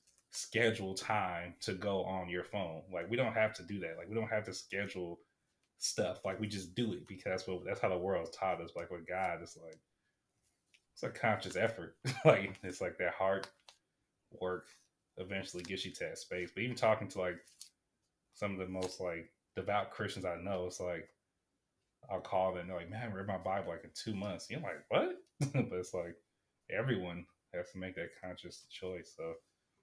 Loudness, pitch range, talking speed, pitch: -38 LUFS, 90-110 Hz, 205 wpm, 95 Hz